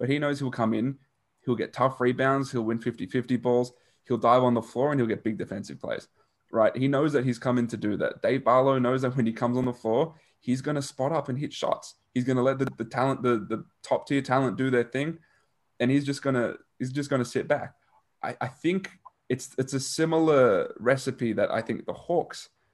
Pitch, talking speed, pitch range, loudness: 130 Hz, 230 wpm, 120-135 Hz, -27 LUFS